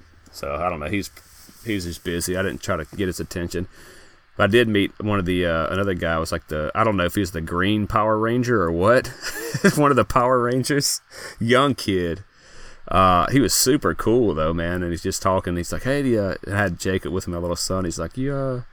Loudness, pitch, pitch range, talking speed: -21 LUFS, 95 Hz, 85-110 Hz, 240 wpm